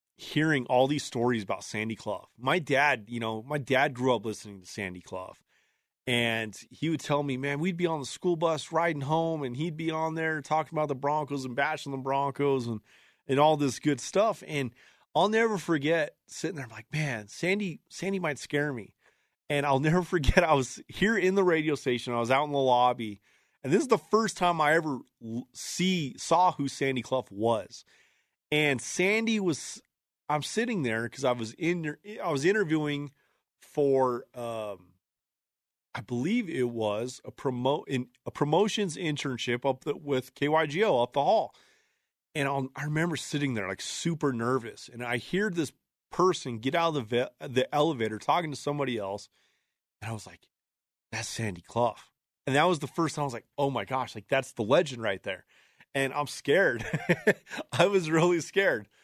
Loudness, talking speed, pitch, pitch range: -29 LUFS, 190 wpm, 140 Hz, 120-160 Hz